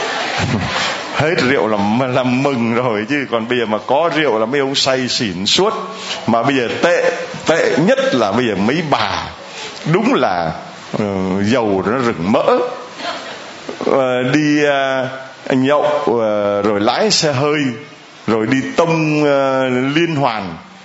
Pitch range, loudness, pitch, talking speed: 115-145 Hz, -15 LUFS, 135 Hz, 150 wpm